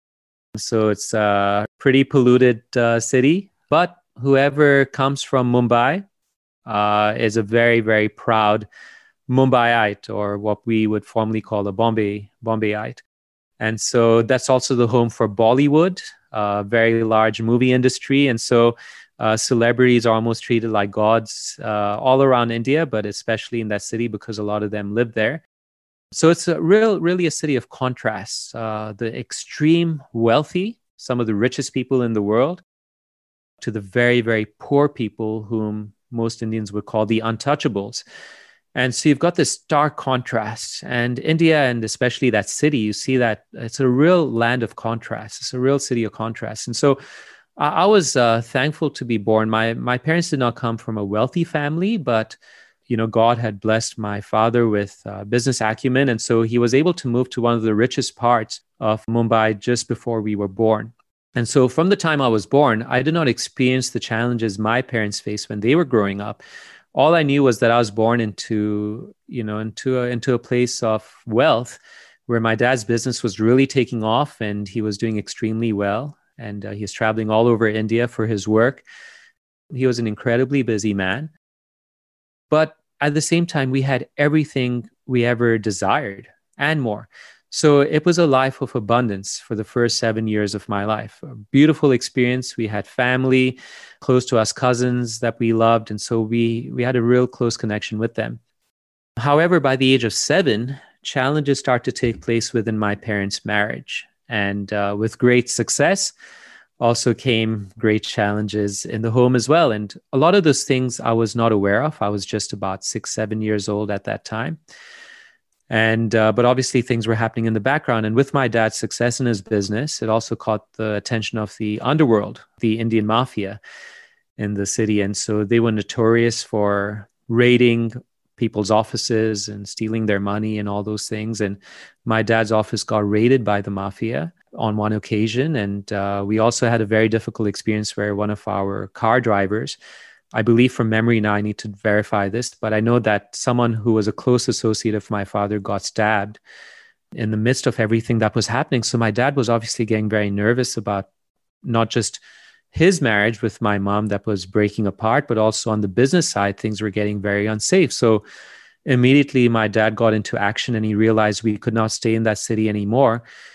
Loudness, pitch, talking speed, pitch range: -19 LUFS, 115 Hz, 190 wpm, 110-130 Hz